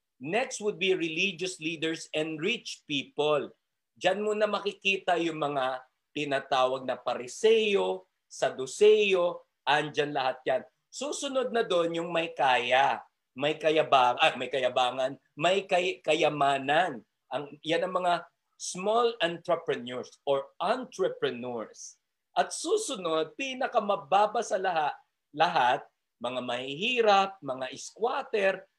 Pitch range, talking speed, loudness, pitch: 145-210 Hz, 110 wpm, -28 LUFS, 170 Hz